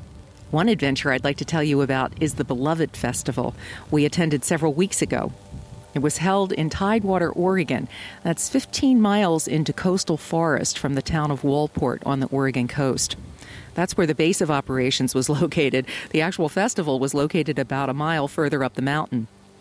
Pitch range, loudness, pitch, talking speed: 135-165 Hz, -22 LUFS, 150 Hz, 175 wpm